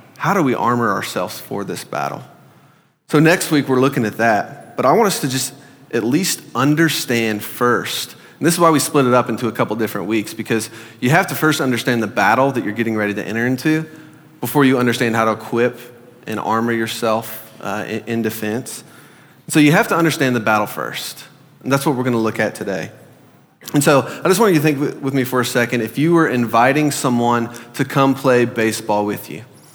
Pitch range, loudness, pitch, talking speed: 110-140 Hz, -17 LUFS, 120 Hz, 215 wpm